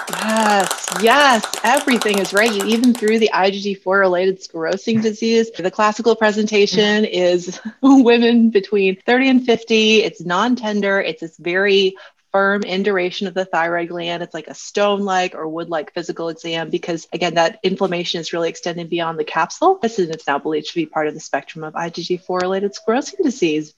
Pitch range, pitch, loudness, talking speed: 170-215 Hz, 190 Hz, -17 LUFS, 160 wpm